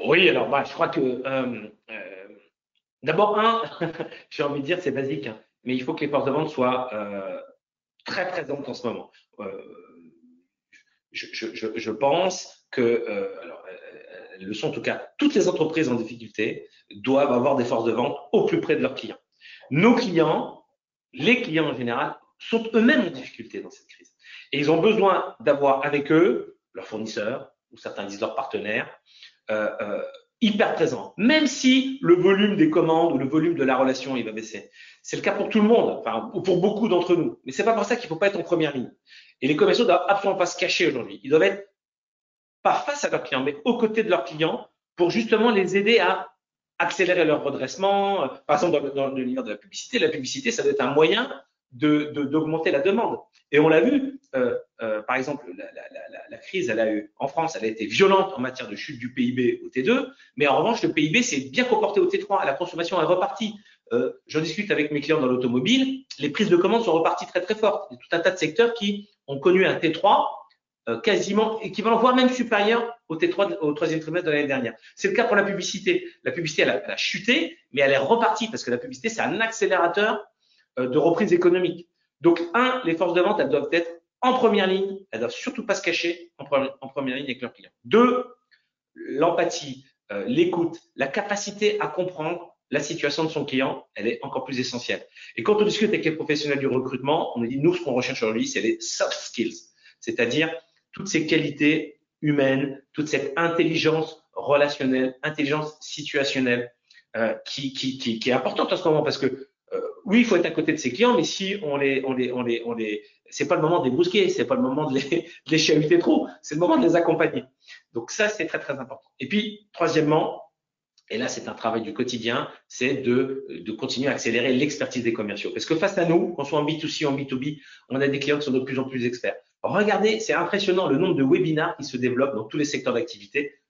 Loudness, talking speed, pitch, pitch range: -23 LUFS, 220 wpm, 170 Hz, 140-225 Hz